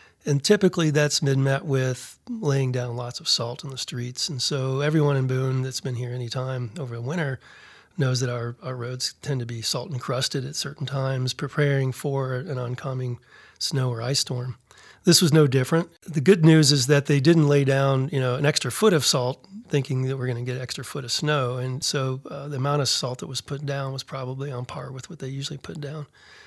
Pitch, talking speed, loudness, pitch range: 135 Hz, 225 wpm, -24 LUFS, 130-145 Hz